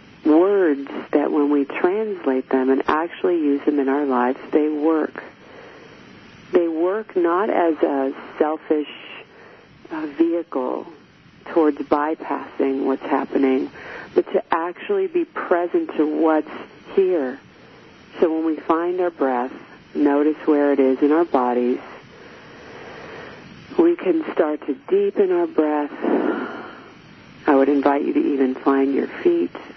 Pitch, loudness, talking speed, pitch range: 155 Hz, -20 LUFS, 125 wpm, 140-215 Hz